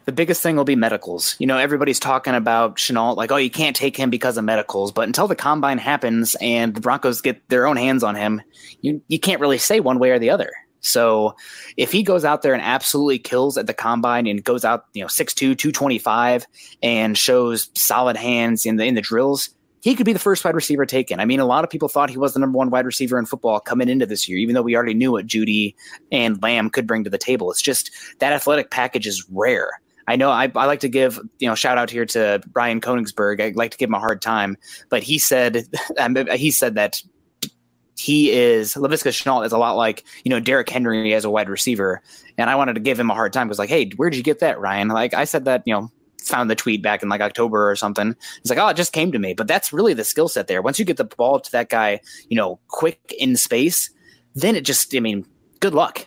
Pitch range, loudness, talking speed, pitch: 110-140 Hz, -19 LUFS, 255 wpm, 125 Hz